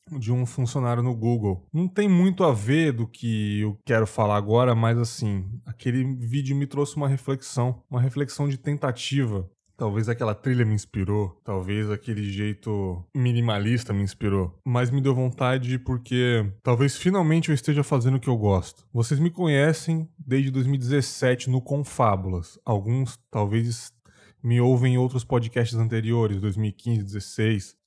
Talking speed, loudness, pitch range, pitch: 150 wpm, -25 LUFS, 105-135 Hz, 120 Hz